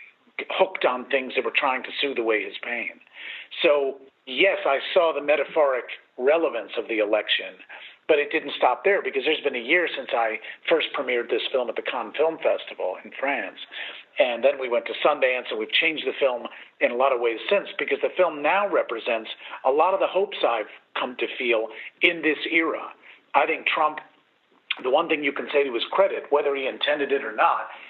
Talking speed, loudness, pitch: 205 wpm, -24 LUFS, 200 Hz